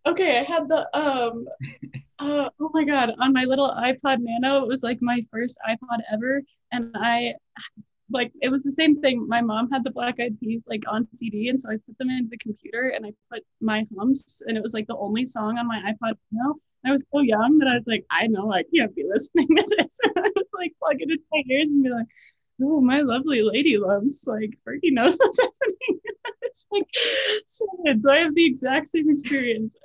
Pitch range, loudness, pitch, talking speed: 230-305 Hz, -23 LUFS, 260 Hz, 225 wpm